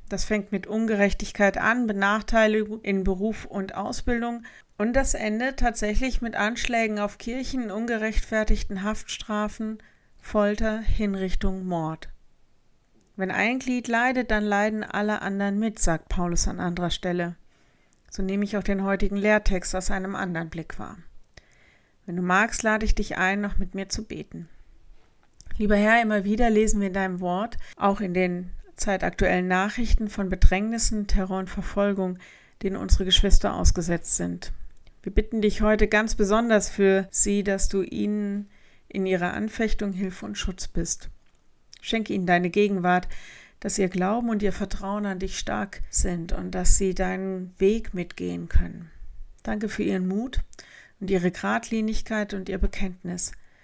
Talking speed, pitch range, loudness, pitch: 150 wpm, 185-215 Hz, -26 LUFS, 200 Hz